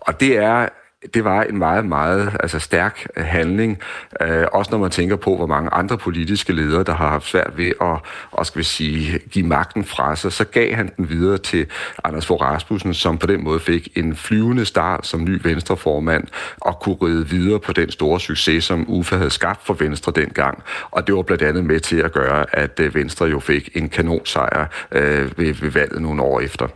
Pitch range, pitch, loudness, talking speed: 80-95 Hz, 85 Hz, -19 LUFS, 210 wpm